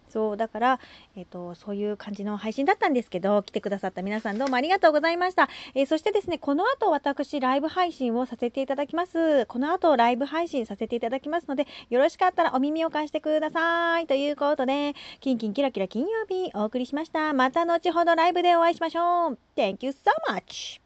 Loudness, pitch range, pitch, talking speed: -25 LUFS, 240-335 Hz, 285 Hz, 480 characters per minute